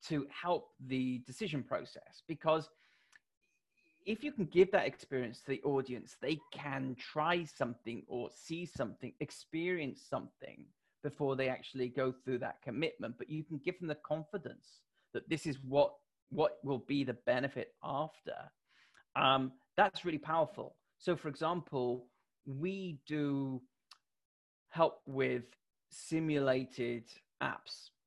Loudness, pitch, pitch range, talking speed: -38 LUFS, 145 Hz, 130-165 Hz, 130 wpm